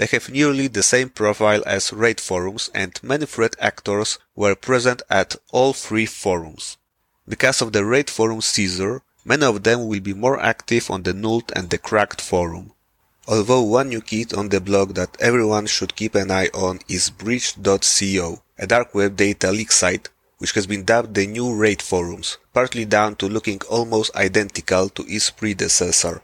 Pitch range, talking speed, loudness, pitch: 100-115 Hz, 180 wpm, -19 LUFS, 105 Hz